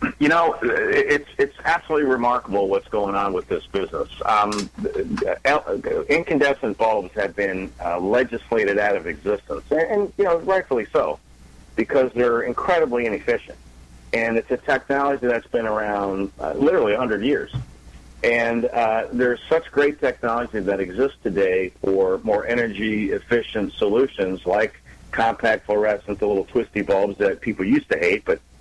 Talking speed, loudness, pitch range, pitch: 150 wpm, -21 LUFS, 100-170 Hz, 120 Hz